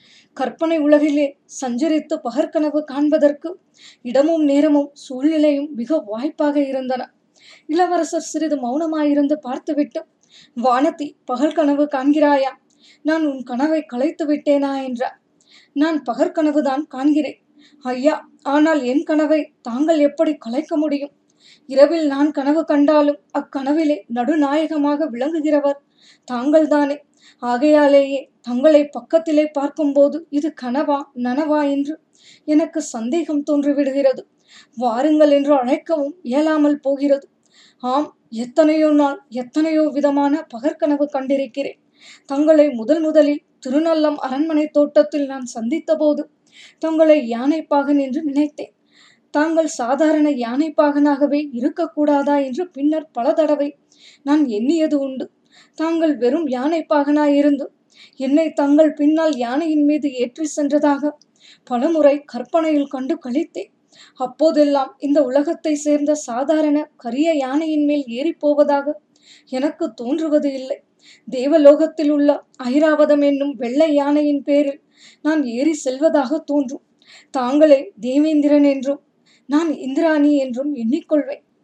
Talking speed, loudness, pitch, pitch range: 100 wpm, -18 LUFS, 295 Hz, 280-310 Hz